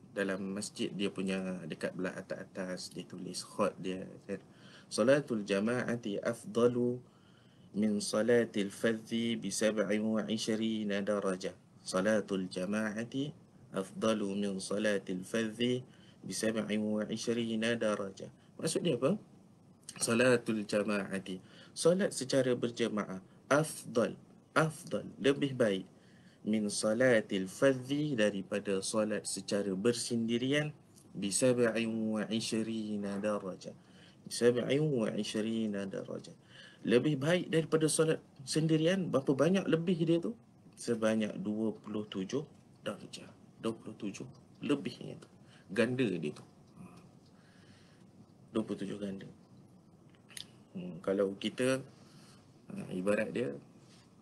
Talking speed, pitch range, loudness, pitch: 85 wpm, 100-130 Hz, -34 LUFS, 110 Hz